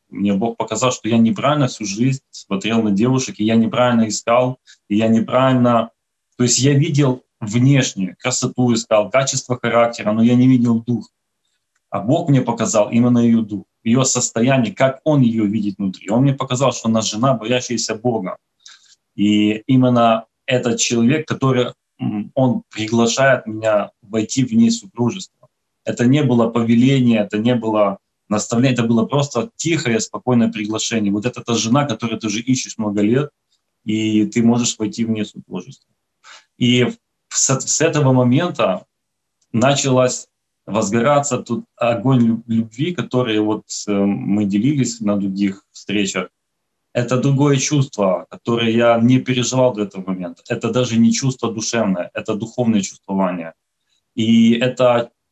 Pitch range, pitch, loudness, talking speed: 110-125 Hz, 115 Hz, -17 LUFS, 145 wpm